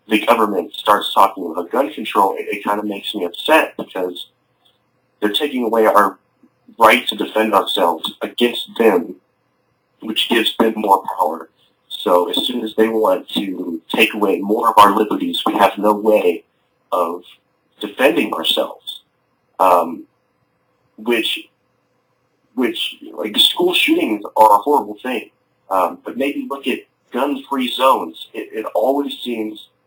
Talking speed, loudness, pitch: 140 wpm, -17 LUFS, 130 Hz